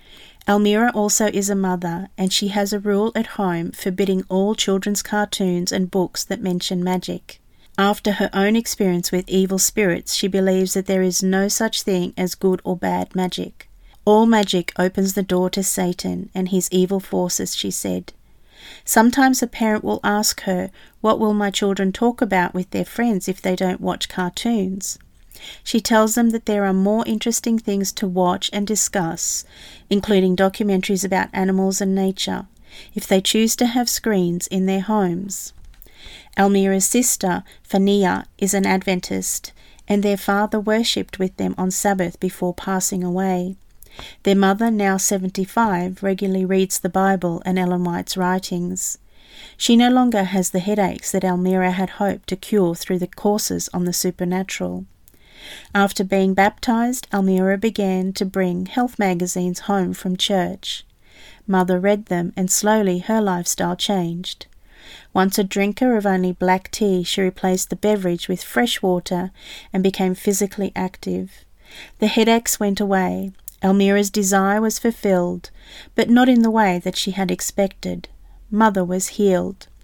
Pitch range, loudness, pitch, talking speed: 185-205 Hz, -19 LUFS, 190 Hz, 155 wpm